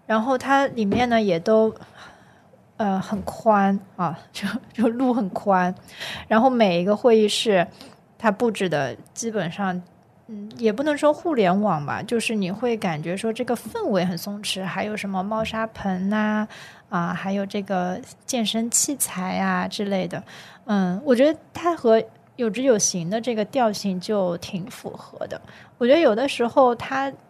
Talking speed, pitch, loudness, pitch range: 230 characters per minute, 215 Hz, -22 LUFS, 190-235 Hz